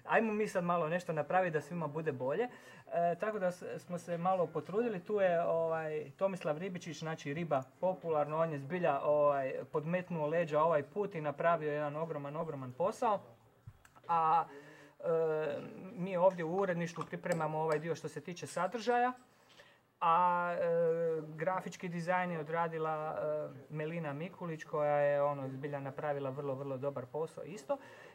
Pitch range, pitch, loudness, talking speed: 150-180 Hz, 165 Hz, -36 LUFS, 155 wpm